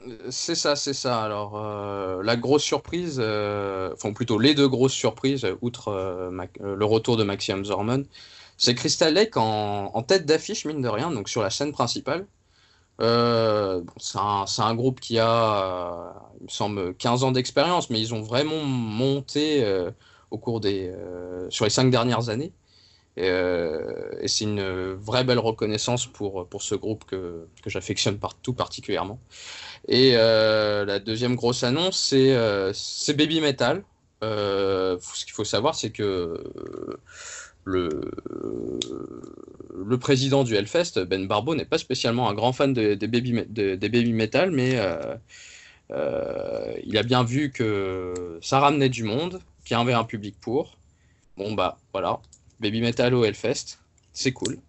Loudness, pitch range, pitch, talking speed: -24 LUFS, 100-140 Hz, 115 Hz, 170 wpm